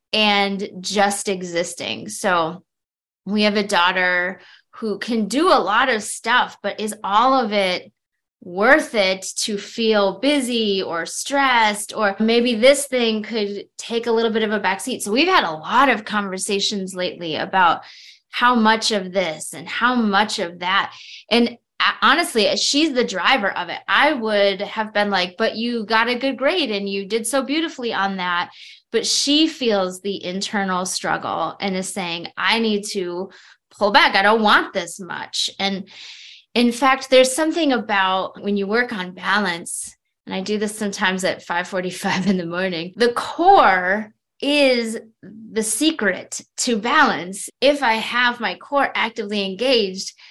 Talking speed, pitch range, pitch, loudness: 160 wpm, 195-240 Hz, 210 Hz, -19 LUFS